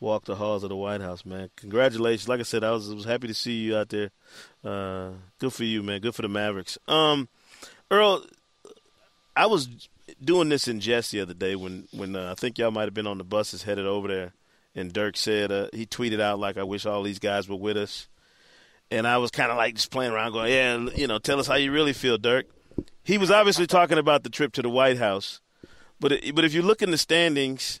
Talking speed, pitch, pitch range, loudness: 240 wpm, 110 Hz, 100-130 Hz, -25 LUFS